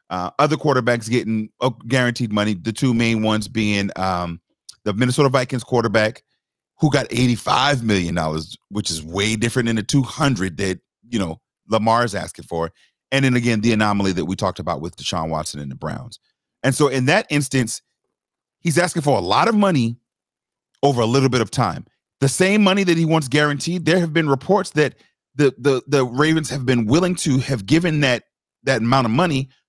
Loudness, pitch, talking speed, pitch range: -19 LUFS, 125 Hz, 195 wpm, 105-145 Hz